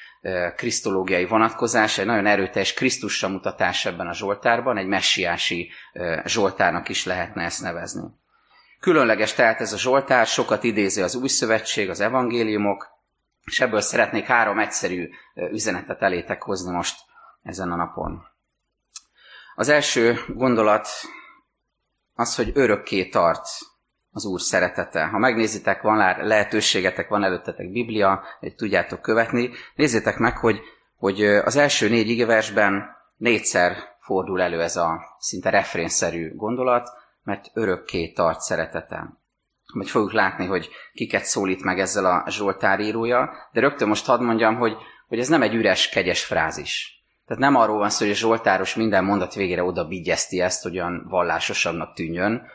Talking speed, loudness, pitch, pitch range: 140 wpm, -21 LUFS, 105 Hz, 95-115 Hz